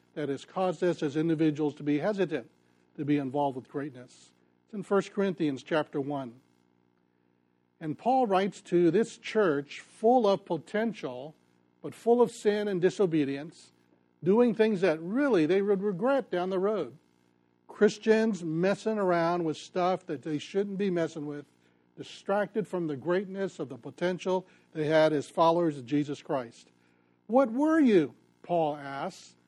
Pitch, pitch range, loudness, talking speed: 160 Hz, 140-195 Hz, -29 LUFS, 155 wpm